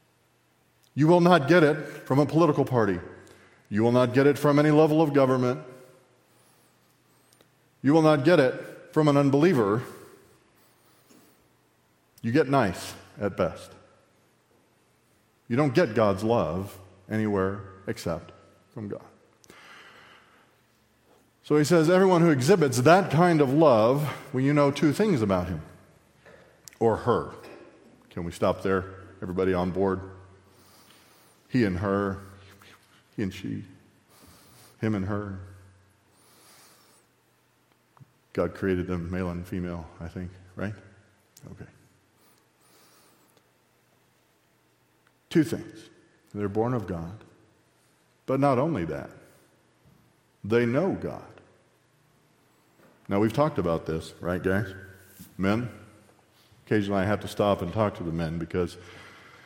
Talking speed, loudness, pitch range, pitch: 120 wpm, -25 LUFS, 95-135 Hz, 105 Hz